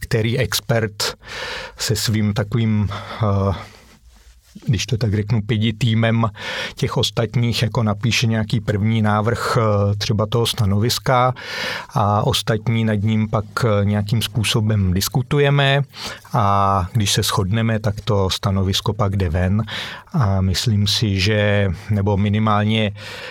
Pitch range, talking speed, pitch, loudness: 100-115 Hz, 115 wpm, 110 Hz, -19 LUFS